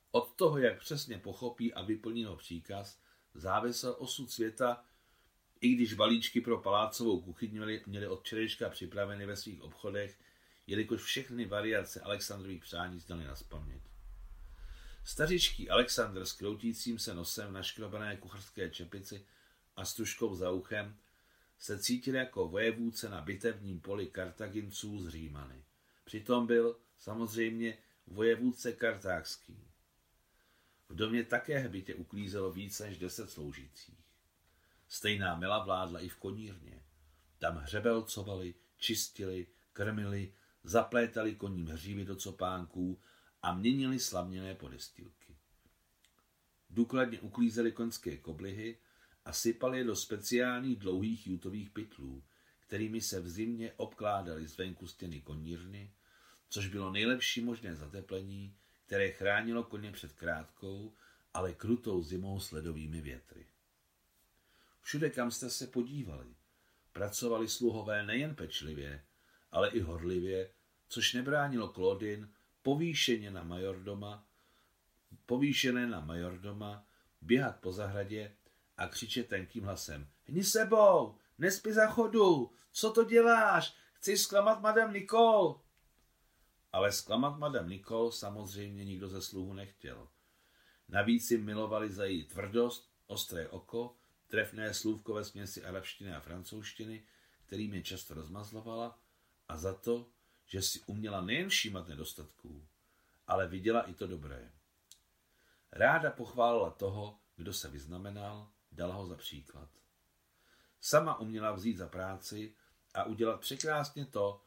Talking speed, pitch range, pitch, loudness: 120 wpm, 90-115 Hz, 100 Hz, -35 LUFS